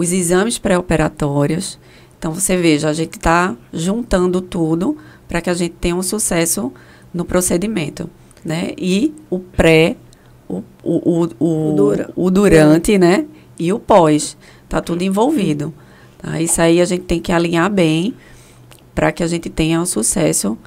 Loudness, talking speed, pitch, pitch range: -16 LUFS, 155 wpm, 170 Hz, 160-180 Hz